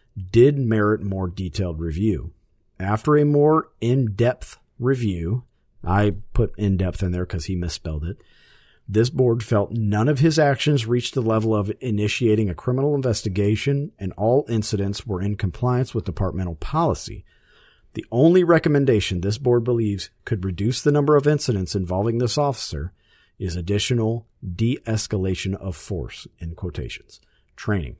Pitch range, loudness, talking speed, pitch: 95-125 Hz, -22 LUFS, 150 wpm, 110 Hz